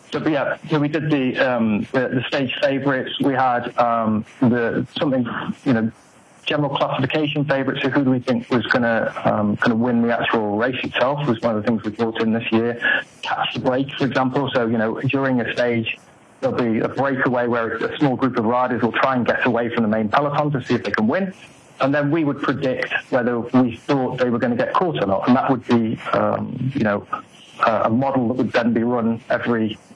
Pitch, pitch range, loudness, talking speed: 125 Hz, 115-140 Hz, -20 LUFS, 225 wpm